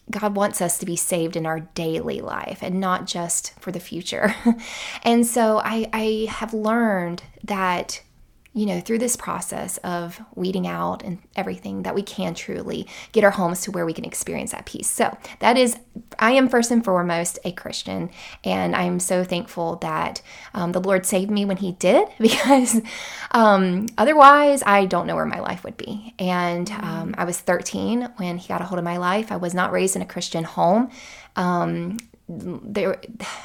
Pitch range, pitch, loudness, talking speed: 175-220 Hz, 195 Hz, -21 LUFS, 185 wpm